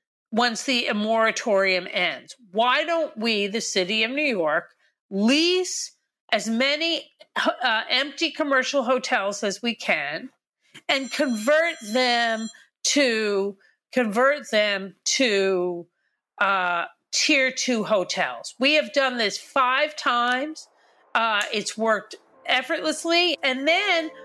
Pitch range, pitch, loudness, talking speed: 210-290 Hz, 250 Hz, -22 LUFS, 110 wpm